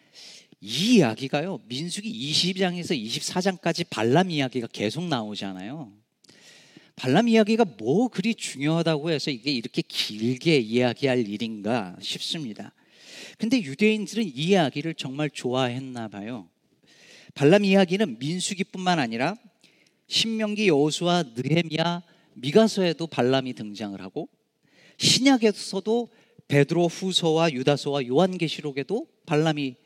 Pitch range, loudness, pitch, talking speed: 135-195 Hz, -24 LUFS, 165 Hz, 290 characters per minute